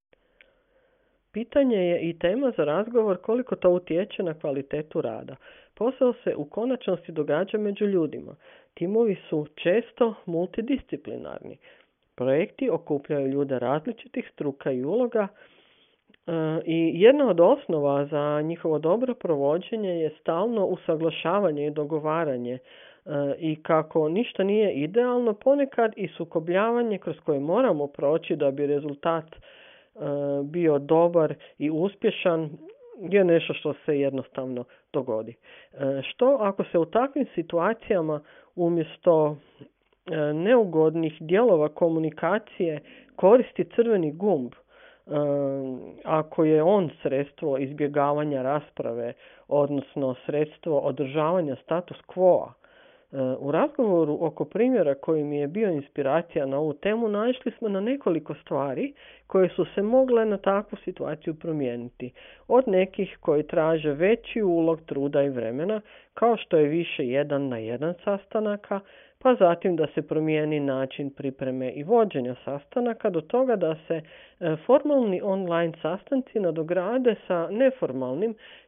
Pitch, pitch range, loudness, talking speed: 165 Hz, 150-215 Hz, -25 LUFS, 115 wpm